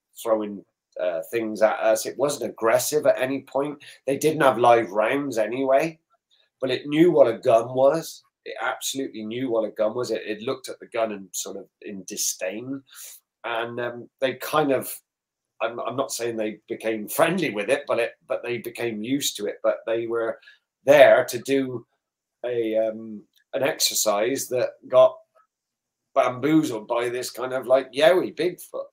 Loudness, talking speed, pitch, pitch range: -23 LUFS, 170 wpm, 120 Hz, 110-140 Hz